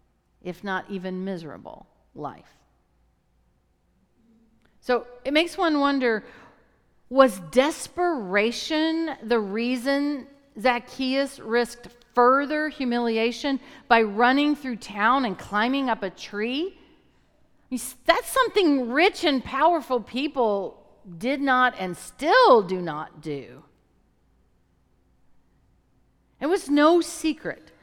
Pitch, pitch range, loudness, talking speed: 245 Hz, 195-290 Hz, -23 LUFS, 95 wpm